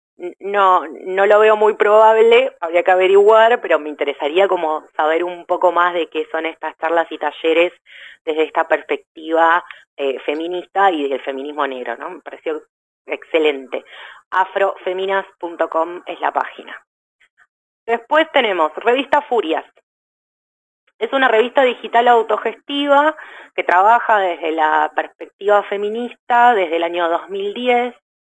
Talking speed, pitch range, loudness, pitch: 125 wpm, 160-230 Hz, -16 LUFS, 185 Hz